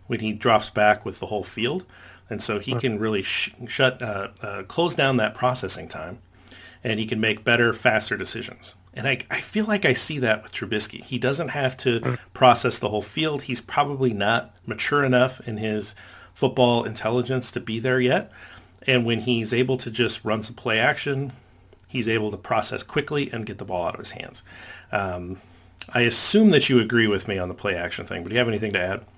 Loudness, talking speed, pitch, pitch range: -23 LUFS, 210 wpm, 115 Hz, 105-130 Hz